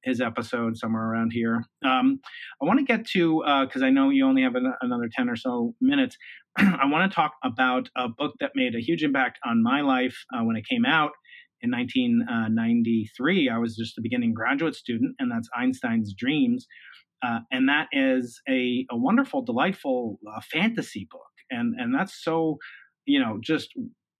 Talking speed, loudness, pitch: 185 wpm, -25 LUFS, 225 Hz